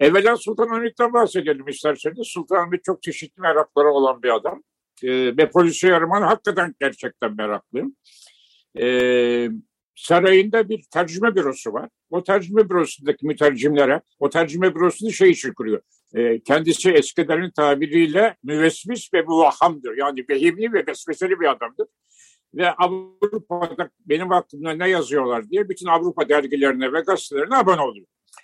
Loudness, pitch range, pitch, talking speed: -20 LUFS, 150-220 Hz, 175 Hz, 135 wpm